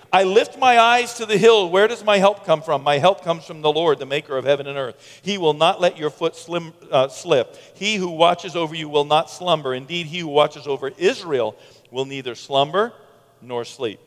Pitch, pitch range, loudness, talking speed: 165 Hz, 140-195 Hz, -19 LUFS, 225 wpm